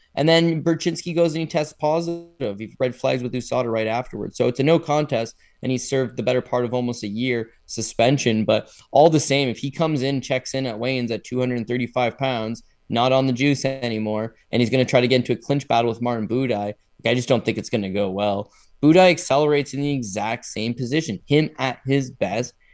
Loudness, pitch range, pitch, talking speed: -22 LUFS, 115-145 Hz, 125 Hz, 225 wpm